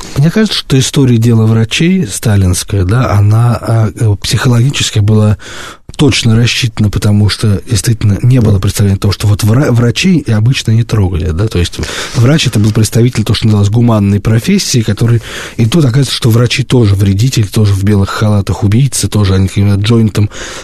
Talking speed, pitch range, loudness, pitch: 160 wpm, 105-120 Hz, -10 LUFS, 110 Hz